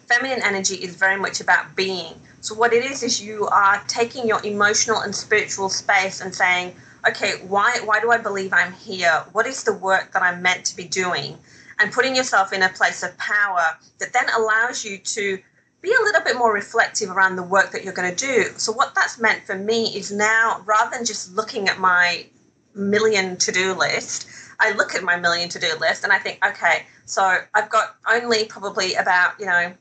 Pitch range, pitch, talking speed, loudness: 190-225 Hz, 205 Hz, 210 wpm, -19 LUFS